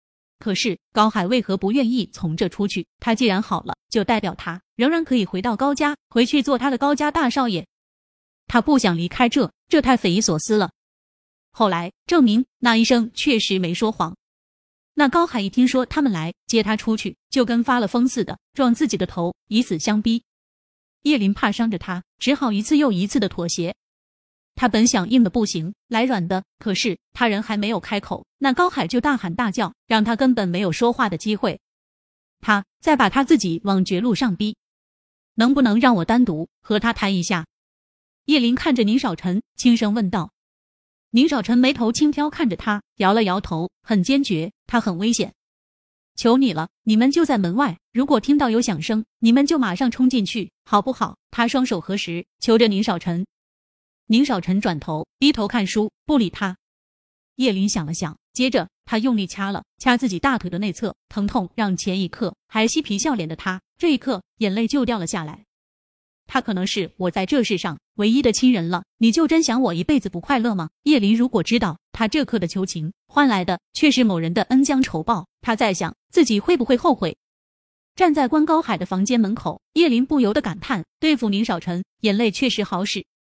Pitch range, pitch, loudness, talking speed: 190-255 Hz, 225 Hz, -20 LUFS, 275 characters per minute